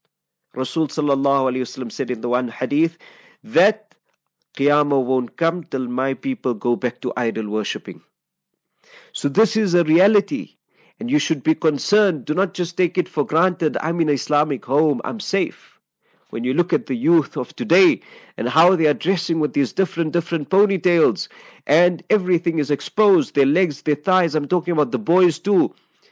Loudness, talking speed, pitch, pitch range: -20 LUFS, 170 wpm, 155 Hz, 135-175 Hz